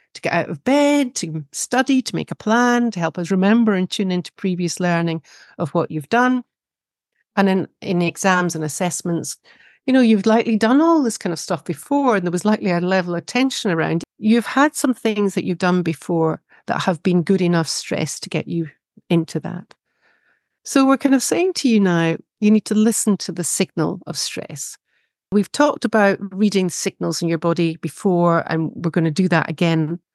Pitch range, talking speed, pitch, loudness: 170-225 Hz, 205 wpm, 185 Hz, -19 LUFS